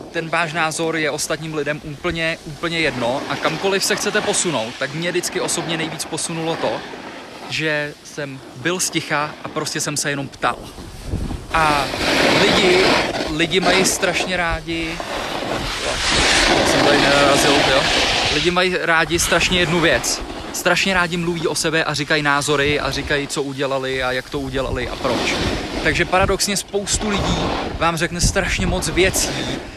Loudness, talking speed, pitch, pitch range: -18 LUFS, 145 wpm, 160 Hz, 145-175 Hz